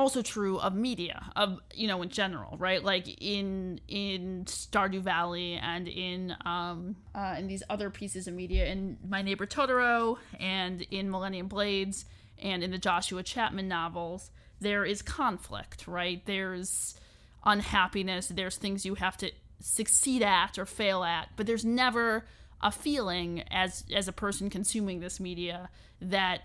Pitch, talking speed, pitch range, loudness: 190 Hz, 155 wpm, 180-205 Hz, -31 LUFS